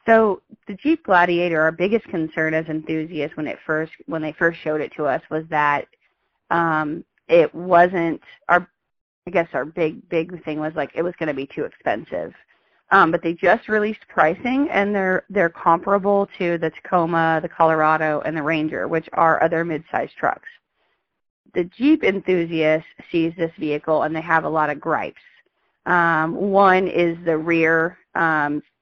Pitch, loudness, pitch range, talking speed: 165 Hz, -20 LUFS, 155-185 Hz, 175 wpm